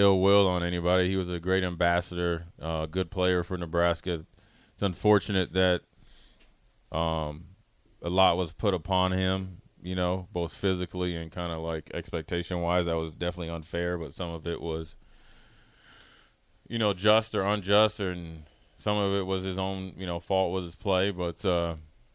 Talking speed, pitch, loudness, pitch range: 165 wpm, 90 Hz, -29 LUFS, 85-95 Hz